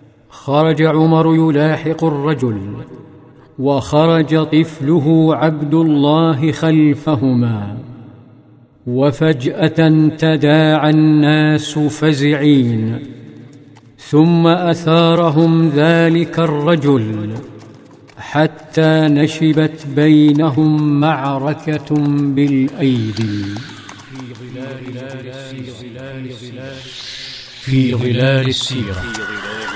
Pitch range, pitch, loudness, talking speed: 130-155 Hz, 150 Hz, -14 LUFS, 50 wpm